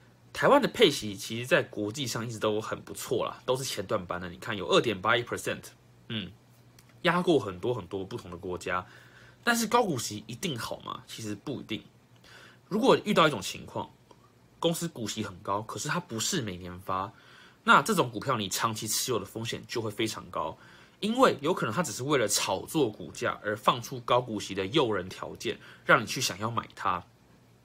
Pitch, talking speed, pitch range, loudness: 110 Hz, 295 characters per minute, 100-125 Hz, -29 LUFS